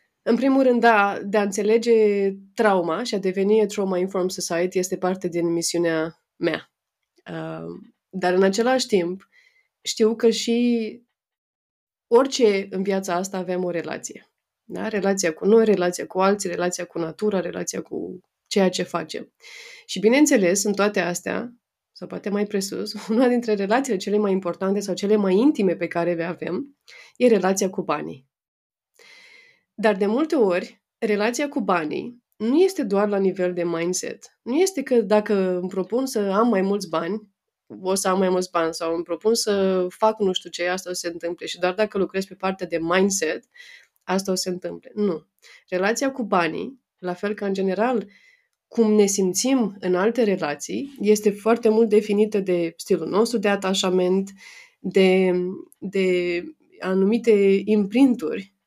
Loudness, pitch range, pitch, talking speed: -22 LUFS, 180-225 Hz, 200 Hz, 165 wpm